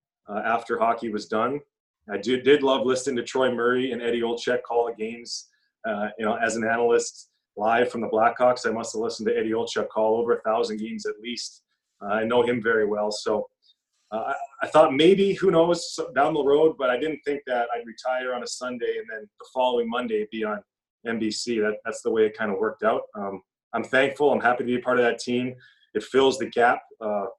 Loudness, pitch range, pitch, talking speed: -24 LUFS, 115-155 Hz, 125 Hz, 225 wpm